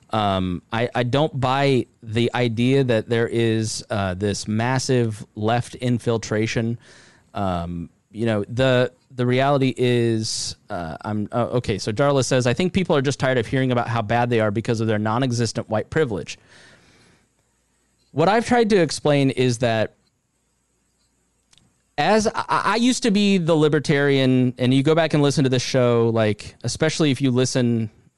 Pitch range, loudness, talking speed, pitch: 115-135 Hz, -21 LUFS, 165 wpm, 120 Hz